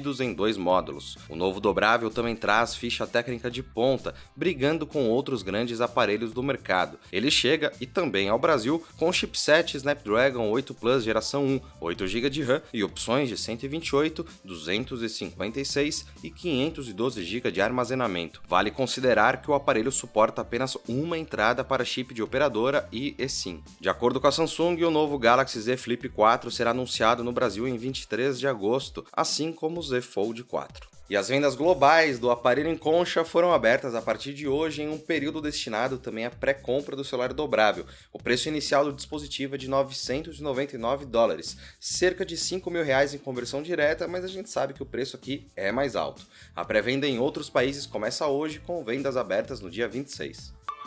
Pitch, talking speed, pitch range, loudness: 130 Hz, 175 wpm, 120-145 Hz, -26 LUFS